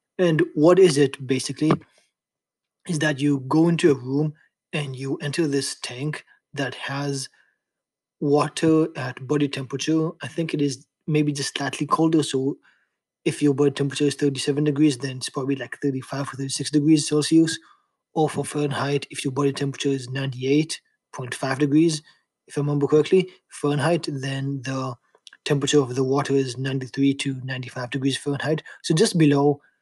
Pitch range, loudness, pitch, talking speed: 135-155 Hz, -23 LUFS, 145 Hz, 155 wpm